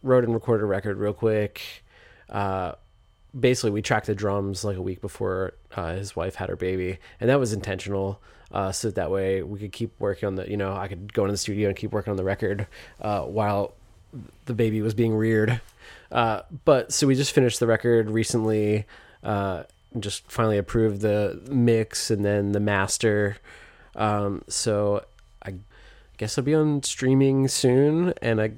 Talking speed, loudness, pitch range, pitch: 190 wpm, -25 LUFS, 100-115 Hz, 105 Hz